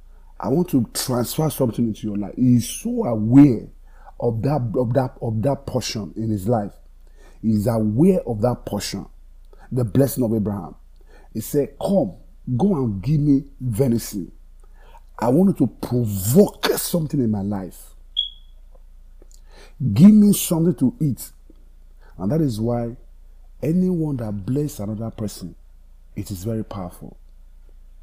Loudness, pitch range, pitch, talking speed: -21 LUFS, 90-135 Hz, 115 Hz, 145 wpm